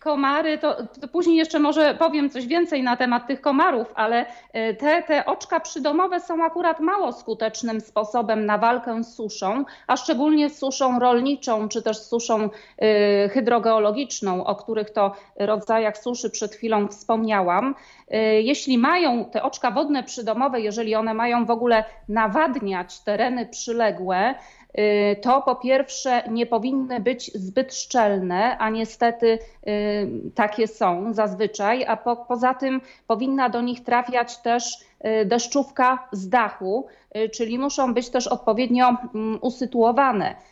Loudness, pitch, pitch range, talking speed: -22 LUFS, 240 Hz, 220-265 Hz, 130 wpm